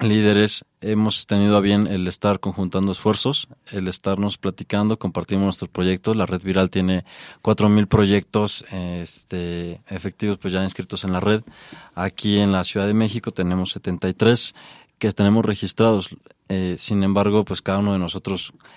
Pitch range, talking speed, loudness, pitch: 95-105 Hz, 155 wpm, -21 LUFS, 100 Hz